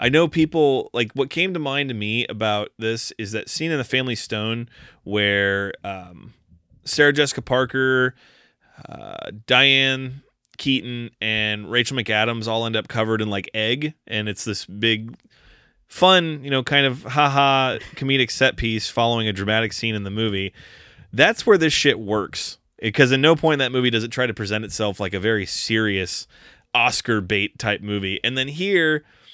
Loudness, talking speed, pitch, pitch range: -20 LUFS, 175 wpm, 115 Hz, 105-135 Hz